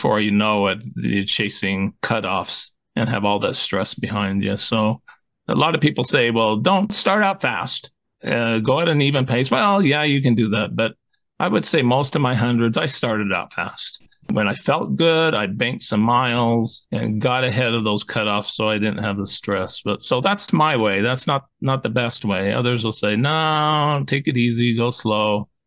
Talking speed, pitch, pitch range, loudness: 210 wpm, 120 Hz, 105-140 Hz, -19 LUFS